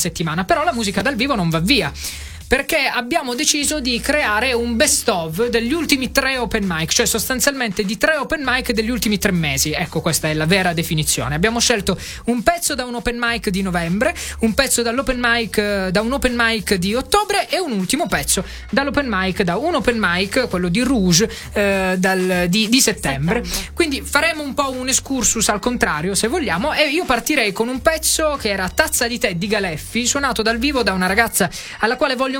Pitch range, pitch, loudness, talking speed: 195-265 Hz, 230 Hz, -18 LUFS, 200 wpm